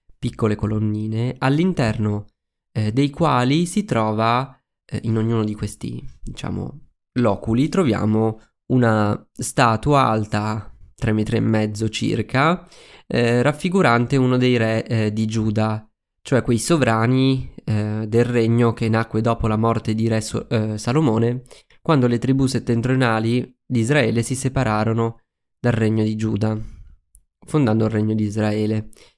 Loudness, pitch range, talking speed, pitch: -20 LUFS, 110-125 Hz, 135 wpm, 115 Hz